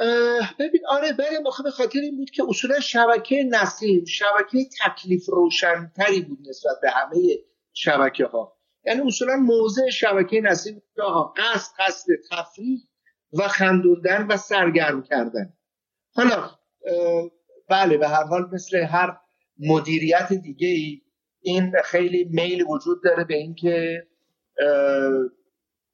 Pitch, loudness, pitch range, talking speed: 185 Hz, -21 LUFS, 170-235 Hz, 125 wpm